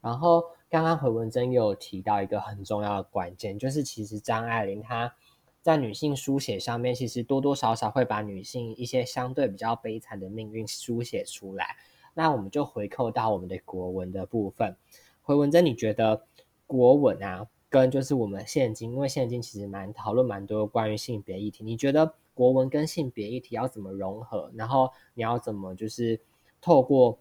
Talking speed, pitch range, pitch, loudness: 290 characters per minute, 105-130 Hz, 115 Hz, -28 LUFS